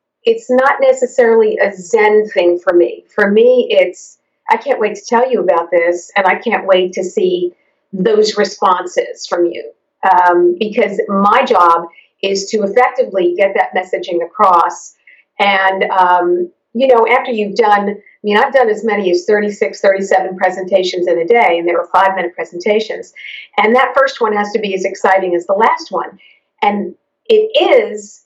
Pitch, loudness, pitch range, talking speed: 205 Hz, -13 LUFS, 185-240 Hz, 175 wpm